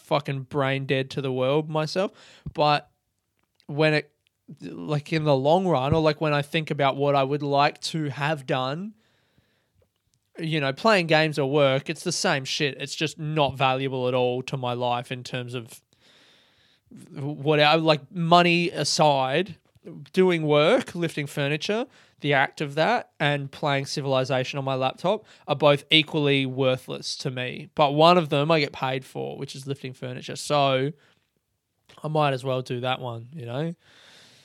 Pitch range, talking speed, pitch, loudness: 135-155 Hz, 170 wpm, 145 Hz, -24 LUFS